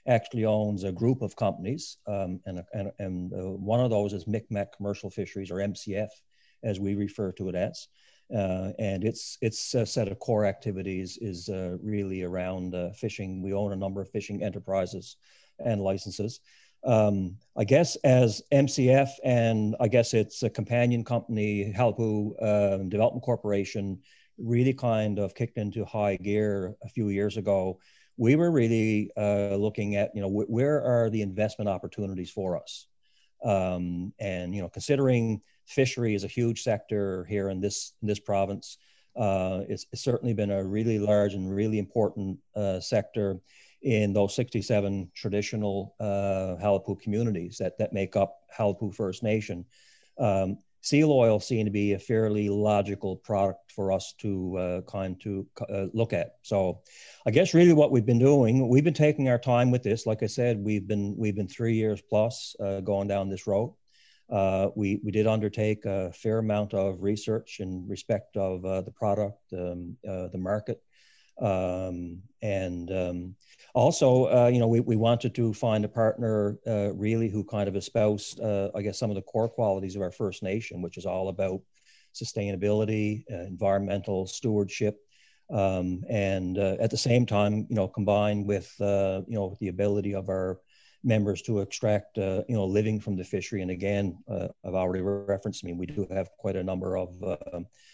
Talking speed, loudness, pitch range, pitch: 175 wpm, -28 LUFS, 95-110 Hz, 105 Hz